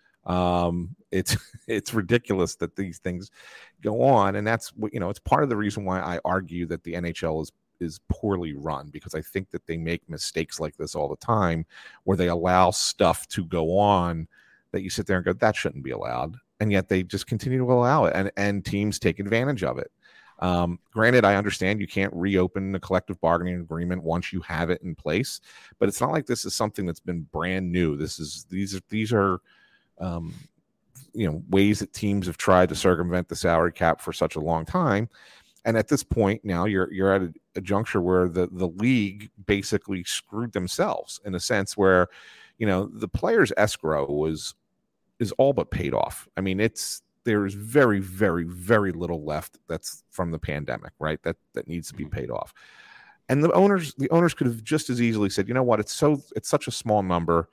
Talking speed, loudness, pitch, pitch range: 210 wpm, -25 LUFS, 95 Hz, 85-105 Hz